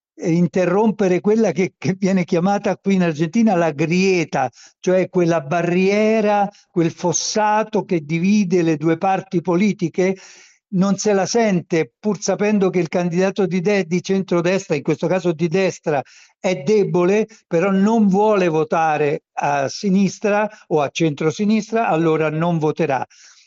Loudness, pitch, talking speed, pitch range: -18 LUFS, 185 Hz, 140 wpm, 170-200 Hz